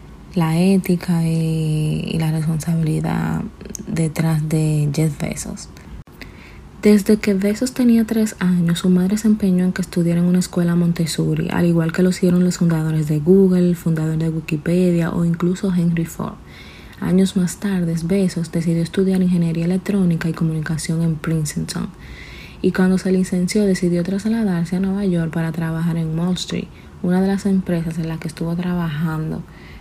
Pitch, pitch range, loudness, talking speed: 170 Hz, 160-185 Hz, -19 LUFS, 160 wpm